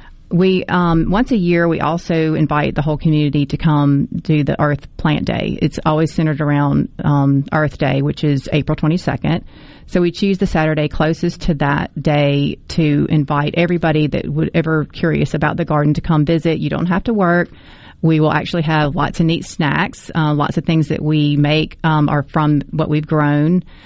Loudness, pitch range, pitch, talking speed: -16 LUFS, 150-170 Hz, 155 Hz, 195 wpm